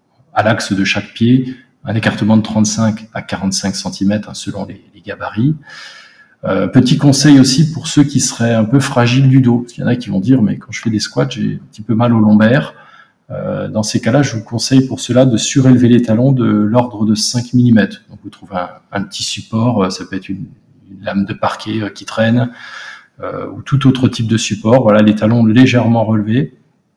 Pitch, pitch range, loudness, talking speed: 115 Hz, 110-130 Hz, -13 LUFS, 220 wpm